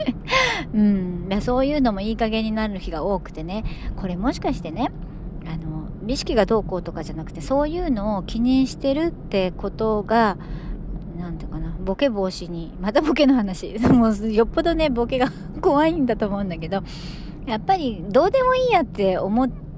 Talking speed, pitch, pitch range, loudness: 350 characters per minute, 205 Hz, 175-255 Hz, -22 LUFS